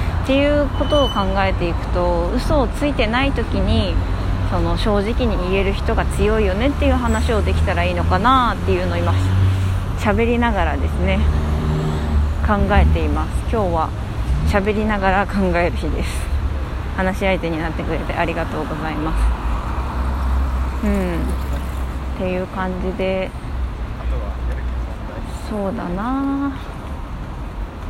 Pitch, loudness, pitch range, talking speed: 80 Hz, -20 LUFS, 70-95 Hz, 265 characters per minute